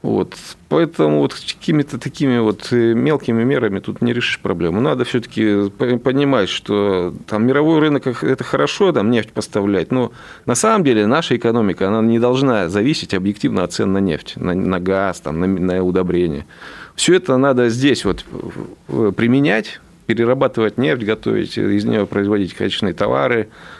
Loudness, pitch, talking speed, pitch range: -17 LUFS, 110 Hz, 155 wpm, 95-130 Hz